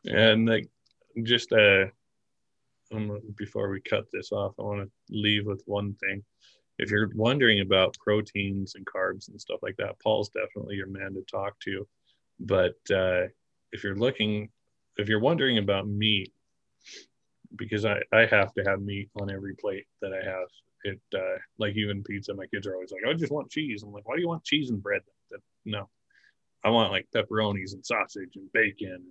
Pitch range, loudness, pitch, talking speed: 100-115 Hz, -28 LUFS, 105 Hz, 190 wpm